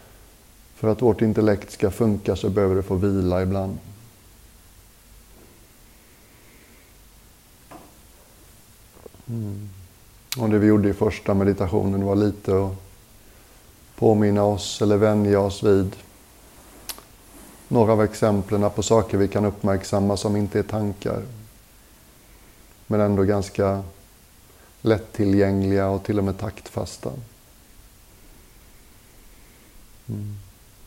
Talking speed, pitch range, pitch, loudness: 100 wpm, 100-110 Hz, 105 Hz, -22 LUFS